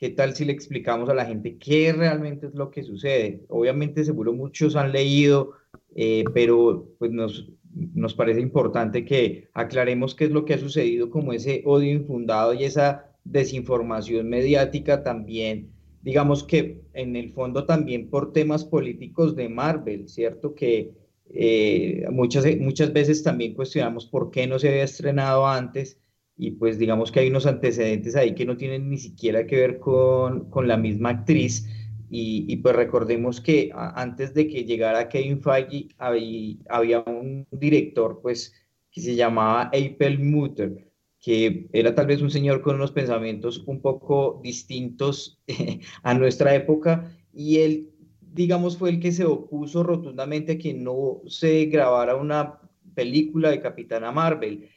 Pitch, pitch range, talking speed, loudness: 135 Hz, 120-150 Hz, 160 wpm, -23 LUFS